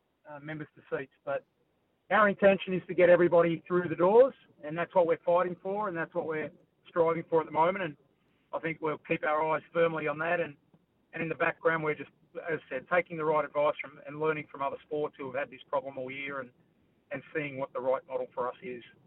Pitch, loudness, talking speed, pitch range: 165 Hz, -30 LUFS, 240 wpm, 150-175 Hz